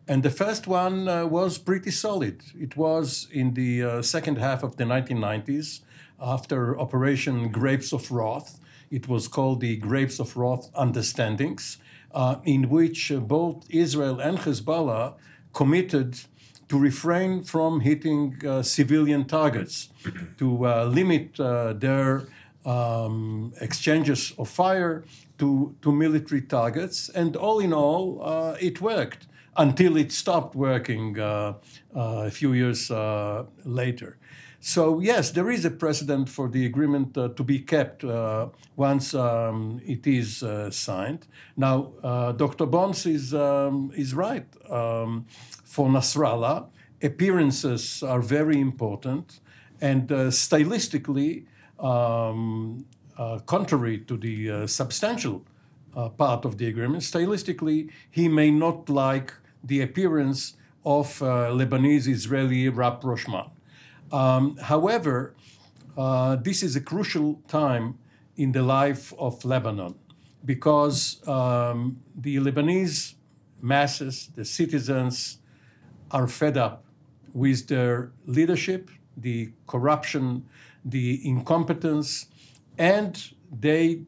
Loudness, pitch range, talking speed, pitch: -25 LUFS, 125-155 Hz, 120 wpm, 140 Hz